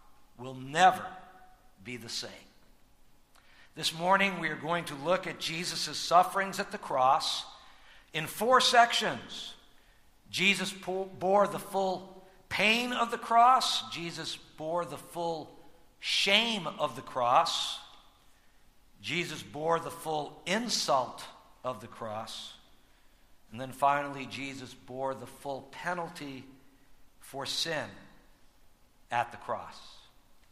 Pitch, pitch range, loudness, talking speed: 165 Hz, 135-190 Hz, -30 LUFS, 115 wpm